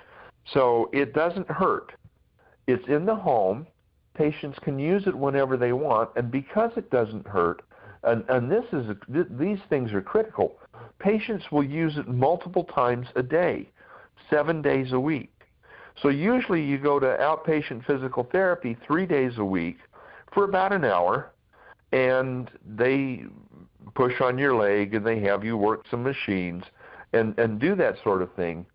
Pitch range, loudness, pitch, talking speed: 115-160 Hz, -25 LUFS, 135 Hz, 165 wpm